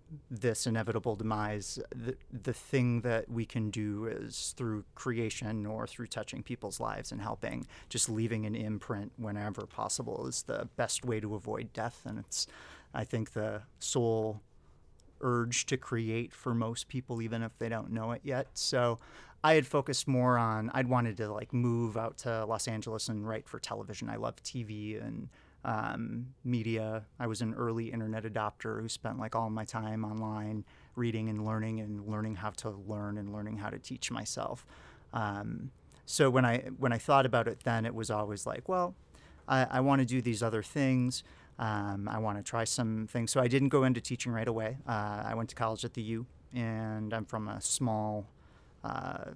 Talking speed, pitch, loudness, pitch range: 190 wpm, 115 Hz, -34 LUFS, 110-125 Hz